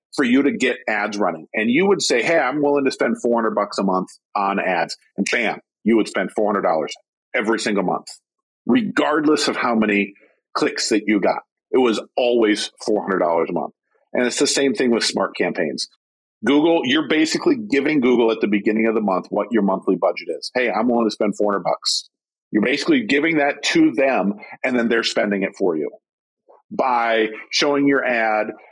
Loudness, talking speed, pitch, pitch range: -19 LUFS, 190 wpm, 120 Hz, 110-145 Hz